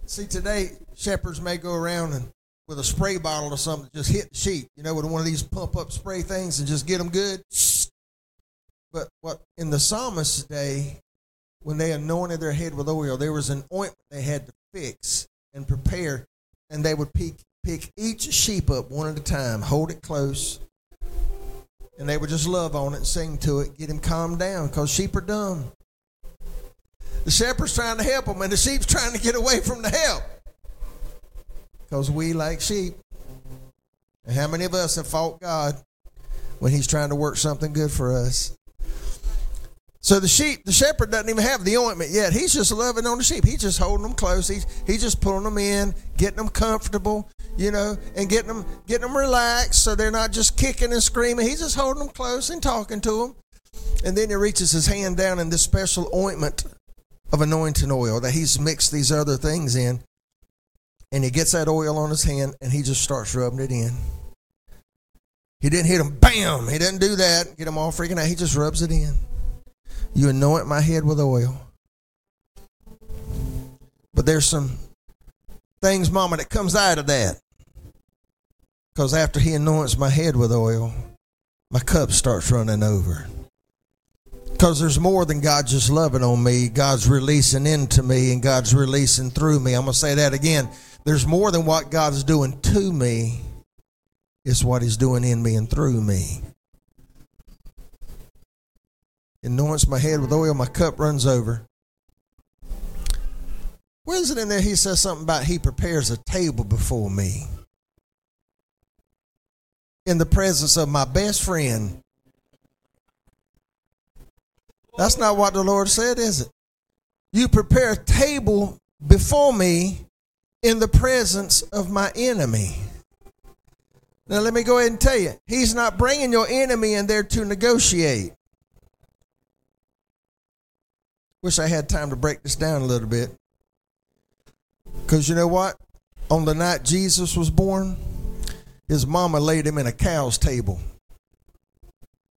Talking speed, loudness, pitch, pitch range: 170 wpm, -21 LUFS, 155 Hz, 130-190 Hz